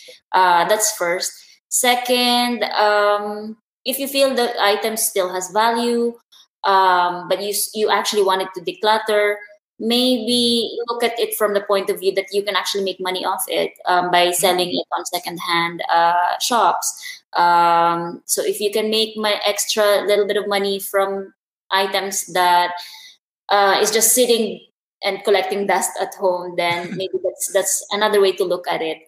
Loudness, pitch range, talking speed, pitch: -18 LUFS, 185-220 Hz, 165 wpm, 200 Hz